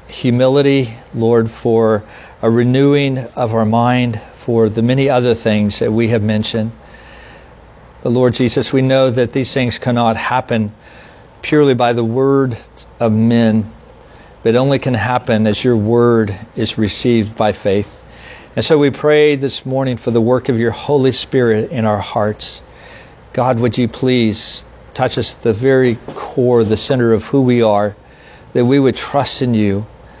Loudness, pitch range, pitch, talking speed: -14 LUFS, 110-130 Hz, 120 Hz, 165 wpm